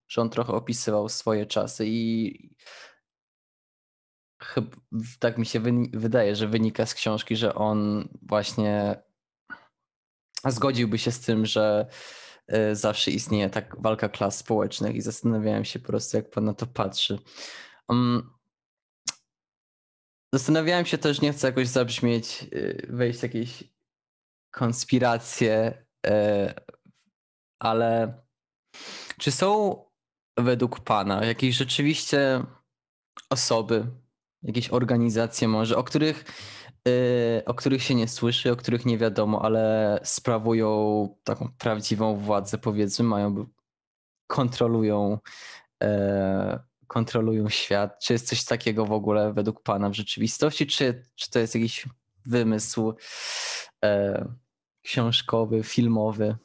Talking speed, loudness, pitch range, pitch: 115 wpm, -26 LUFS, 105-125 Hz, 115 Hz